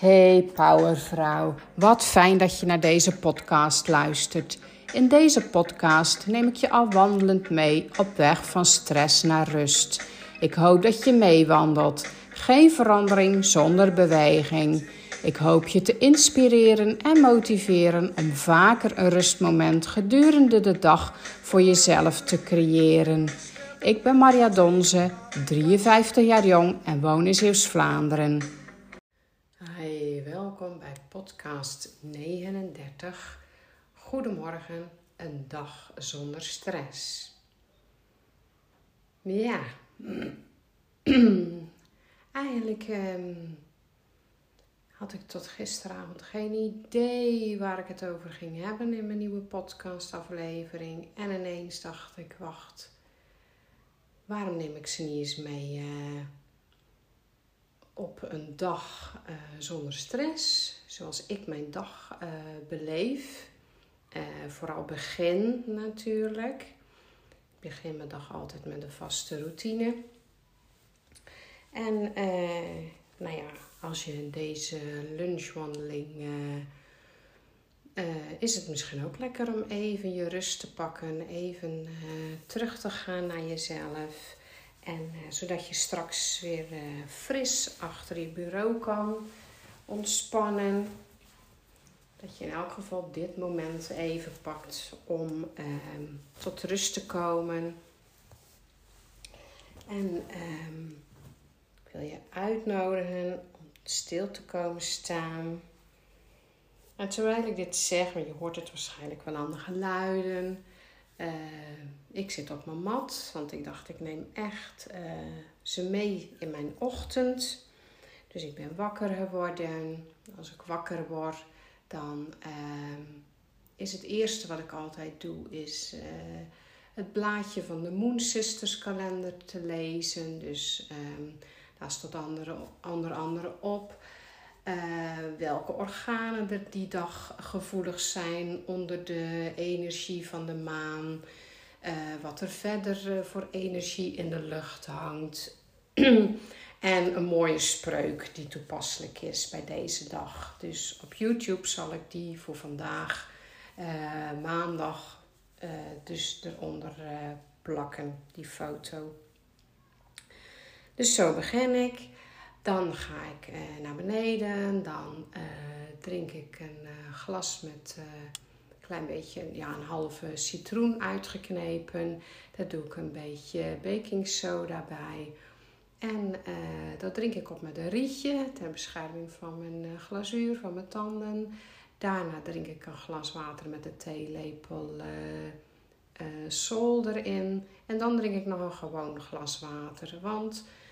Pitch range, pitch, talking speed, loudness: 155-195 Hz, 170 Hz, 120 wpm, -25 LUFS